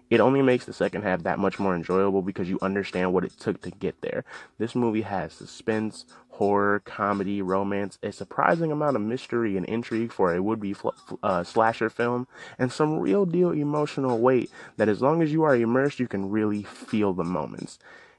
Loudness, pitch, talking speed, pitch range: -26 LUFS, 110 Hz, 195 wpm, 100-125 Hz